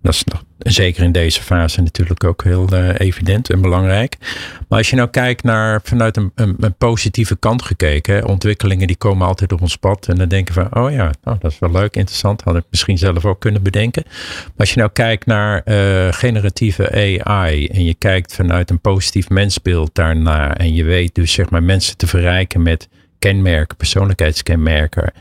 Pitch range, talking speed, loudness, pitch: 90-105 Hz, 195 wpm, -15 LUFS, 95 Hz